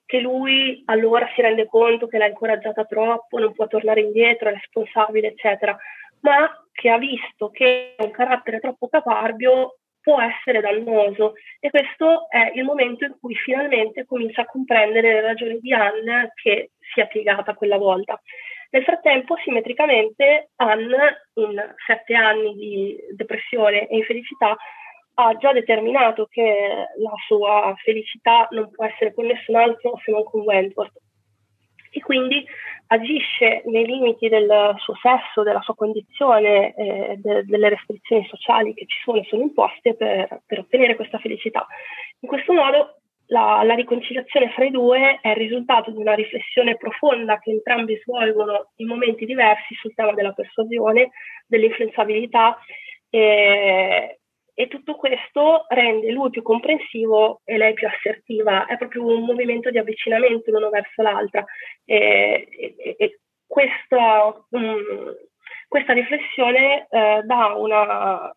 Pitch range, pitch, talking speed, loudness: 215-255 Hz, 230 Hz, 145 wpm, -19 LUFS